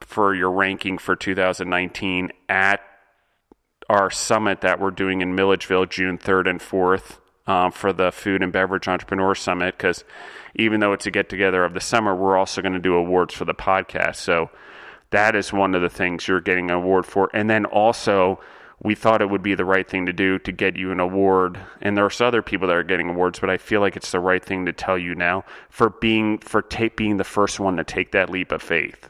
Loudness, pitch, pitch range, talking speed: -21 LUFS, 95 Hz, 90-100 Hz, 225 wpm